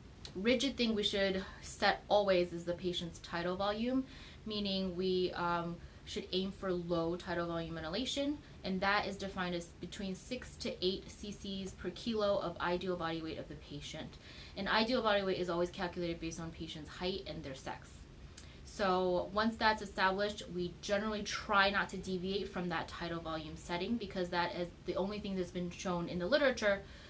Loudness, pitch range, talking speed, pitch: -36 LUFS, 175-200 Hz, 180 wpm, 185 Hz